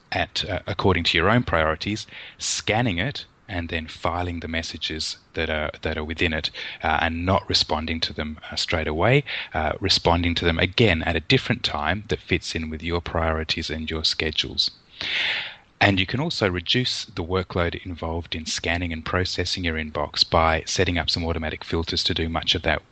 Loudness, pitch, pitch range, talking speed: -23 LUFS, 85 Hz, 80-95 Hz, 190 wpm